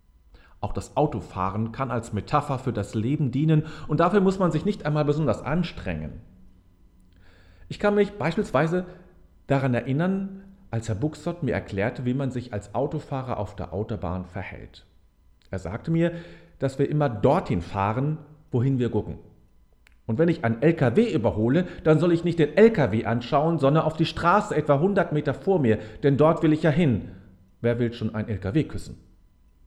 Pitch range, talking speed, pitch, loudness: 95-155 Hz, 170 wpm, 125 Hz, -24 LUFS